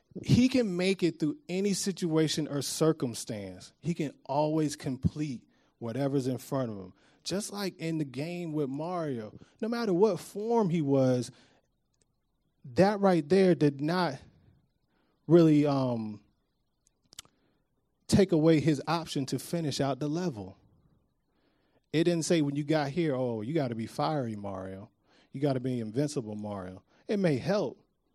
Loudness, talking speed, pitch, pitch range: -29 LUFS, 150 wpm, 150 Hz, 130-170 Hz